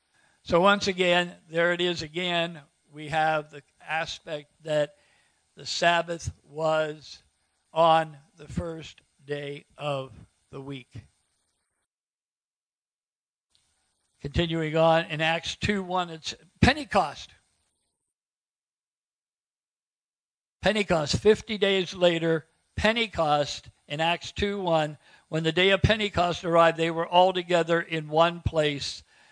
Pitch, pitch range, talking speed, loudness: 160 Hz, 145-175 Hz, 100 wpm, -25 LUFS